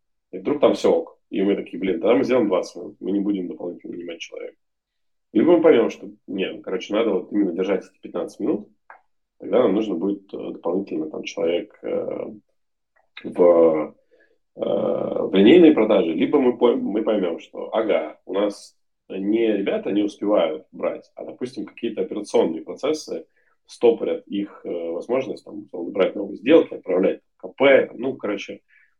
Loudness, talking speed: -21 LUFS, 155 wpm